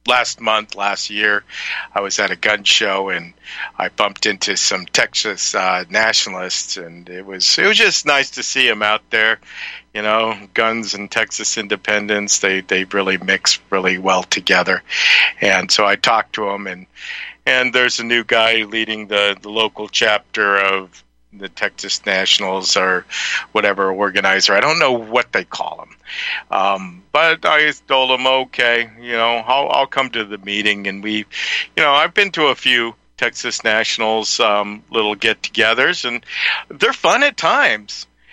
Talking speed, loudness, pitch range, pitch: 170 wpm, -16 LUFS, 95-115 Hz, 105 Hz